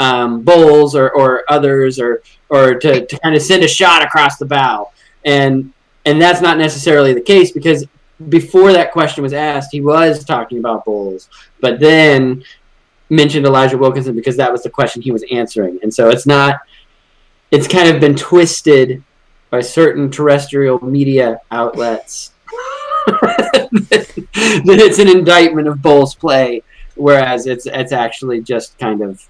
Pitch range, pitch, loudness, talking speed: 130-160 Hz, 145 Hz, -11 LUFS, 155 wpm